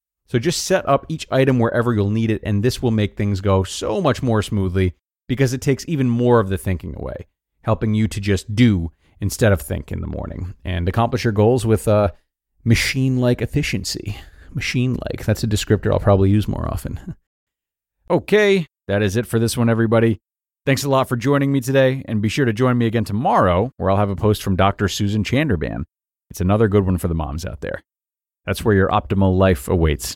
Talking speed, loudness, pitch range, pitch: 205 wpm, -19 LUFS, 95-120 Hz, 105 Hz